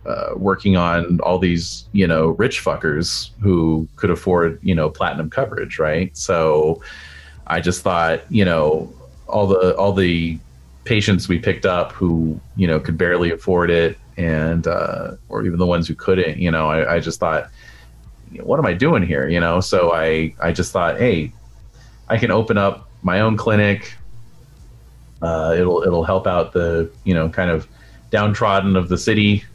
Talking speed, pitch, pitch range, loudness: 175 wpm, 85 Hz, 80-95 Hz, -18 LUFS